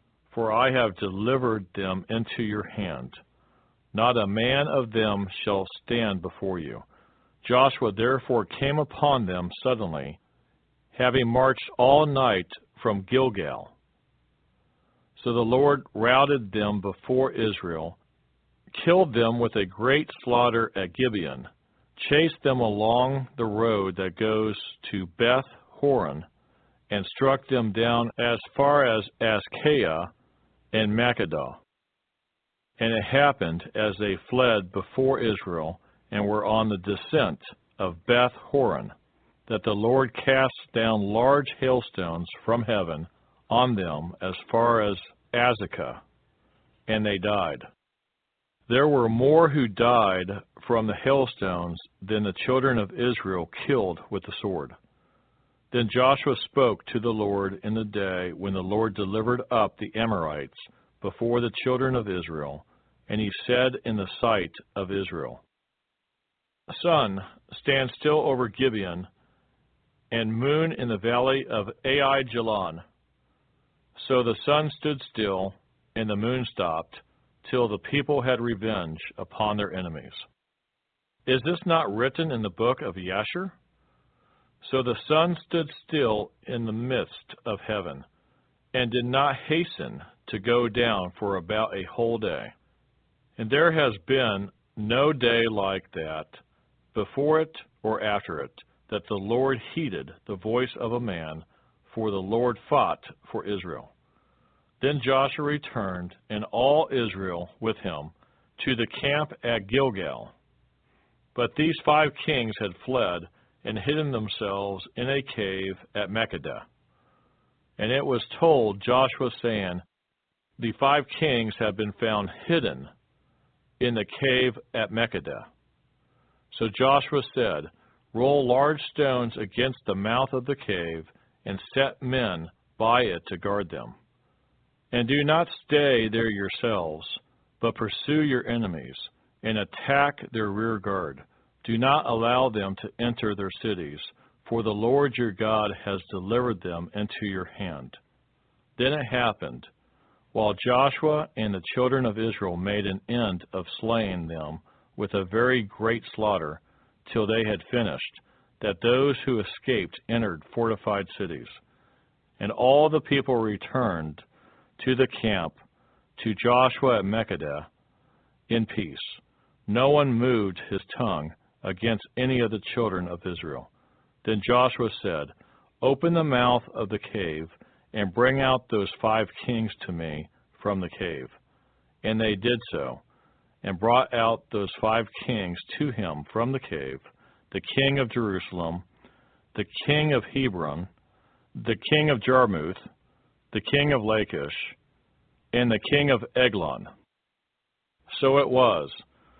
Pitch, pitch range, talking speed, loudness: 115 Hz, 100-130 Hz, 135 wpm, -26 LUFS